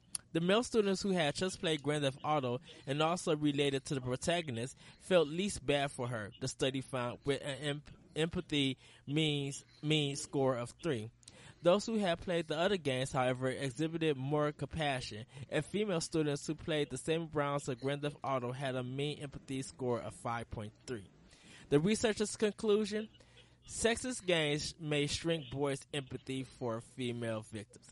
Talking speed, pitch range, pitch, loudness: 165 wpm, 130-165 Hz, 145 Hz, -36 LUFS